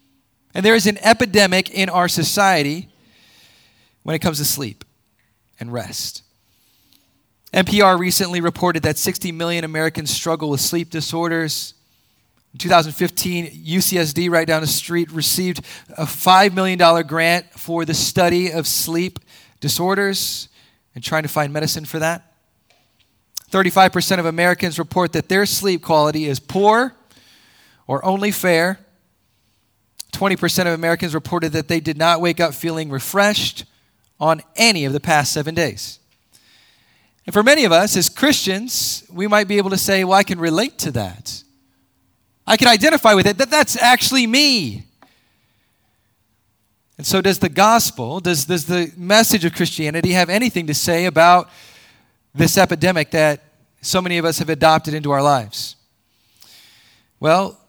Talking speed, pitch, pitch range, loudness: 145 wpm, 165 Hz, 140-185 Hz, -16 LUFS